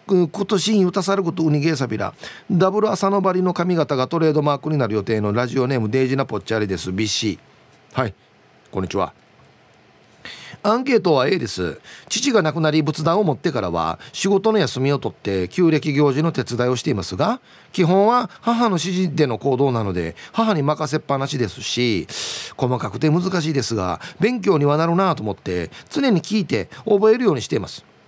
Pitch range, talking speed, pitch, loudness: 125-195 Hz, 370 characters per minute, 155 Hz, -20 LUFS